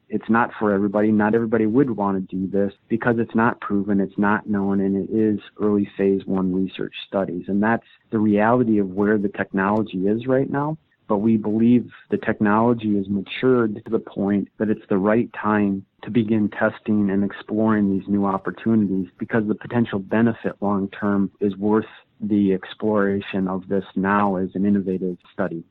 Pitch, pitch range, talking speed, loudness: 105 Hz, 100-110 Hz, 180 wpm, -21 LUFS